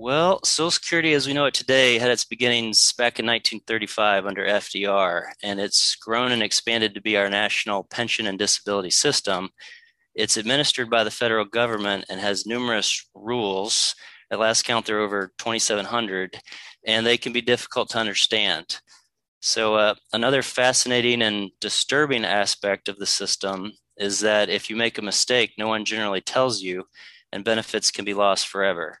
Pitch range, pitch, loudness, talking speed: 100-120 Hz, 110 Hz, -21 LUFS, 170 wpm